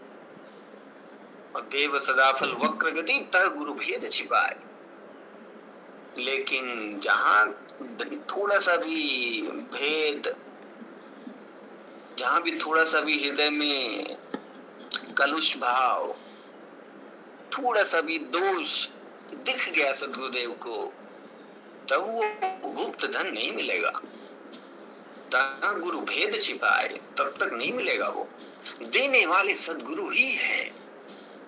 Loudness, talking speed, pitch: -25 LUFS, 95 wpm, 200 Hz